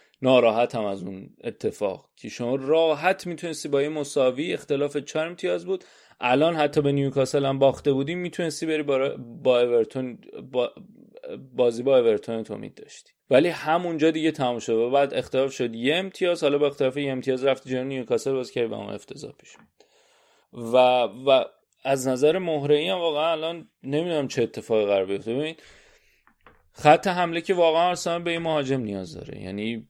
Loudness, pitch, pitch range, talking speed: -24 LUFS, 145 Hz, 130-165 Hz, 175 wpm